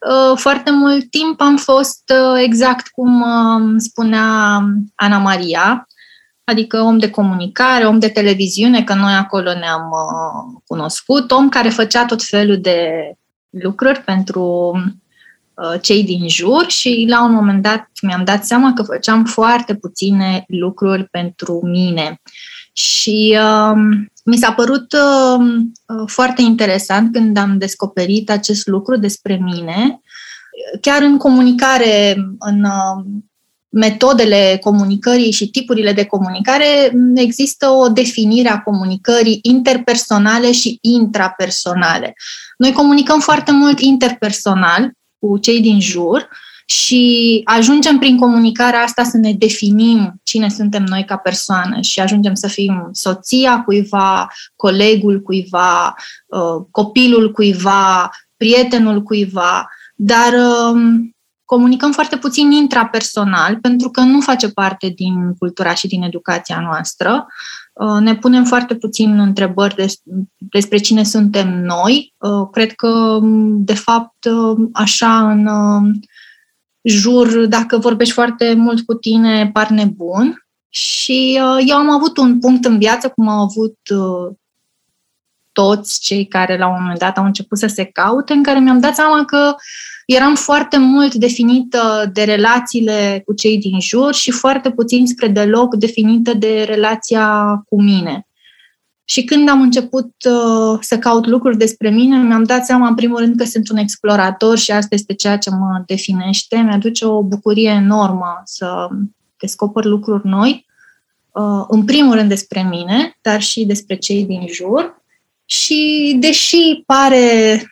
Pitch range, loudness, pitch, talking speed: 200-245 Hz, -12 LUFS, 220 Hz, 130 wpm